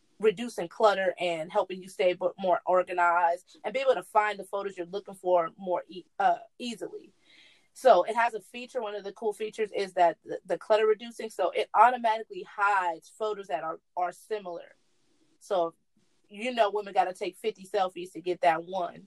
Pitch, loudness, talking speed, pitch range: 200 Hz, -28 LUFS, 190 wpm, 180-225 Hz